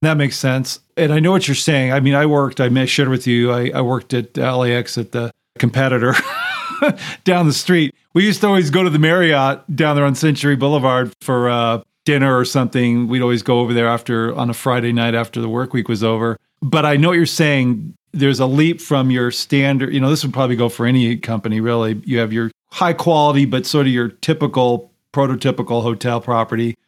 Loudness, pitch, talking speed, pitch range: -16 LUFS, 130 Hz, 215 wpm, 120-145 Hz